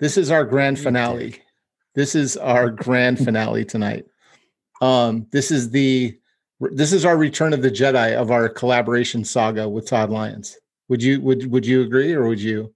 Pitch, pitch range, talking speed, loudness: 125 Hz, 115-135 Hz, 180 wpm, -19 LUFS